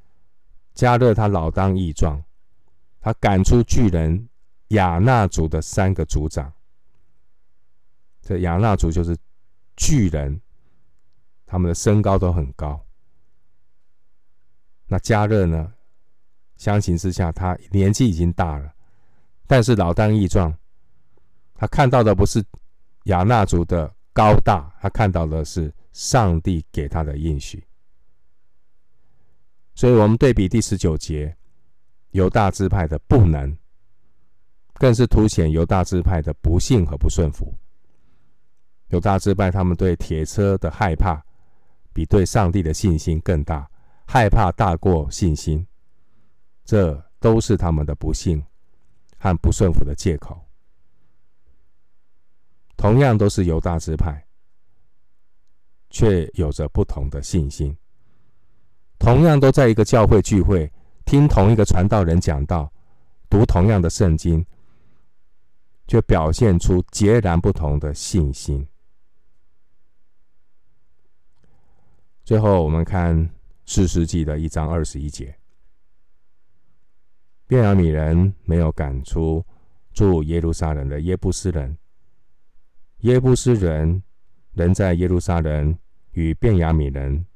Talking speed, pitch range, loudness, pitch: 175 characters per minute, 80-100 Hz, -19 LUFS, 90 Hz